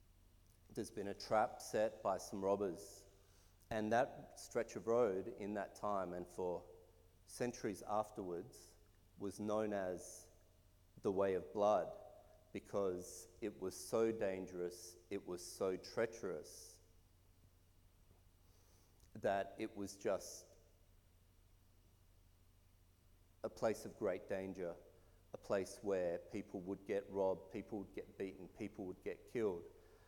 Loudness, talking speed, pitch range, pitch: -43 LUFS, 120 wpm, 90-100 Hz, 90 Hz